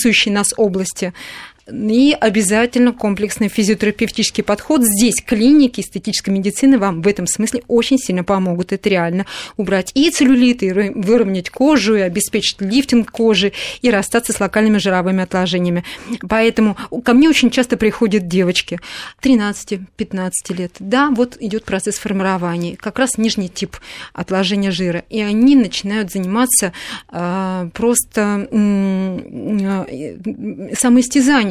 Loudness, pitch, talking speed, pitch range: -15 LUFS, 210 Hz, 120 wpm, 190-235 Hz